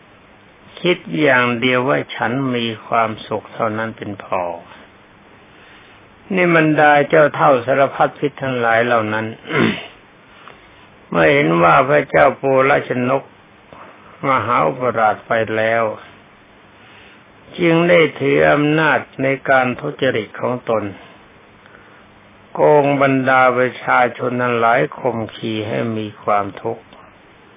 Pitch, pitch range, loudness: 125 Hz, 110-140 Hz, -16 LUFS